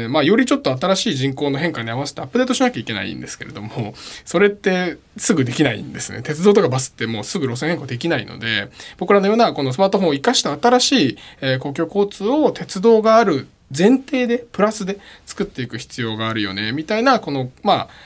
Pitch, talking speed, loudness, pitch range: 170 Hz, 460 characters per minute, -18 LUFS, 135-220 Hz